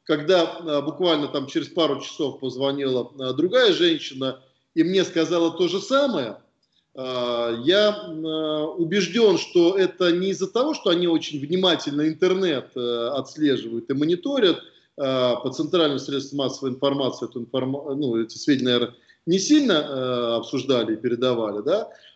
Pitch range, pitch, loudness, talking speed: 130-180 Hz, 150 Hz, -23 LUFS, 145 wpm